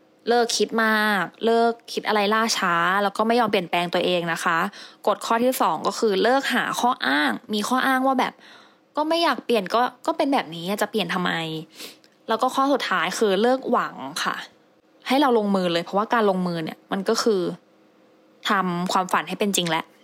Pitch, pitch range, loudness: 215 Hz, 190-240 Hz, -22 LUFS